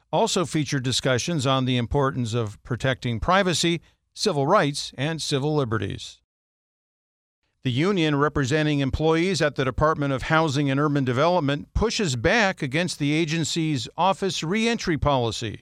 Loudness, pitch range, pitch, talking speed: -23 LUFS, 130-165 Hz, 145 Hz, 130 wpm